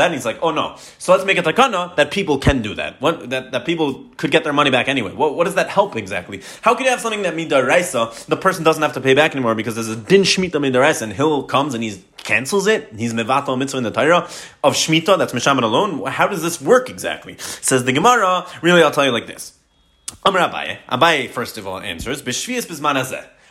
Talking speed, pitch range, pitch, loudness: 235 wpm, 130-180 Hz, 145 Hz, -17 LUFS